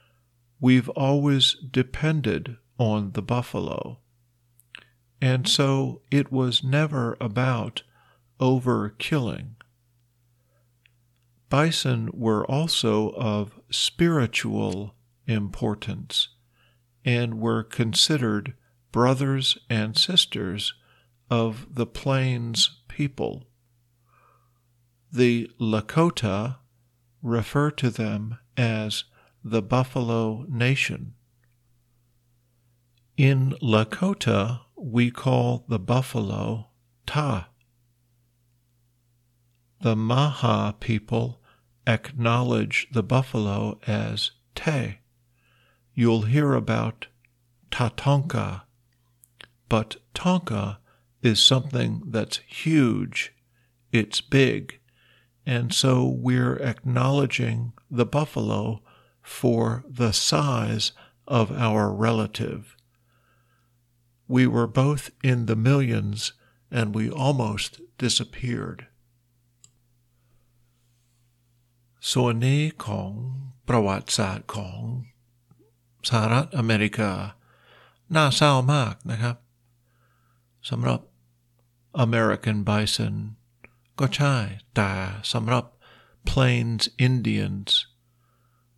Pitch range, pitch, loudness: 115-125 Hz, 120 Hz, -24 LUFS